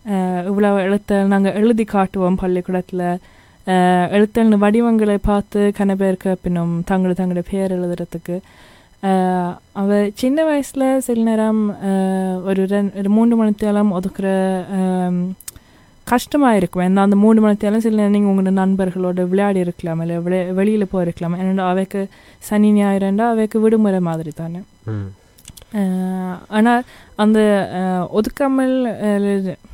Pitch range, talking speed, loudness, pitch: 185-210 Hz, 105 wpm, -17 LUFS, 195 Hz